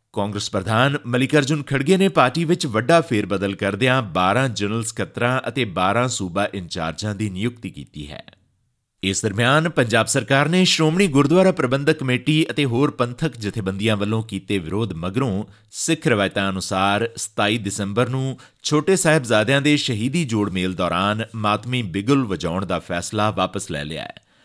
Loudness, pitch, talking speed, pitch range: -20 LUFS, 115 Hz, 150 wpm, 100-140 Hz